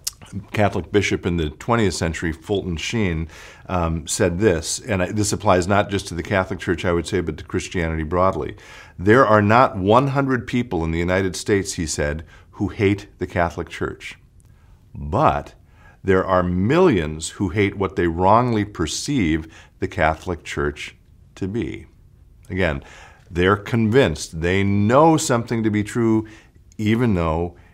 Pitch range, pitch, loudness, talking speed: 85-105 Hz, 95 Hz, -20 LUFS, 150 wpm